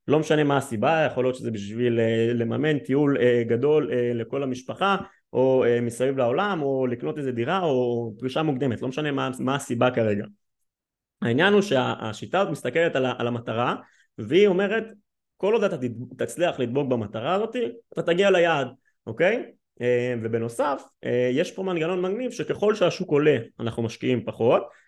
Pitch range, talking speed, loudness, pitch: 120-165 Hz, 145 wpm, -24 LUFS, 130 Hz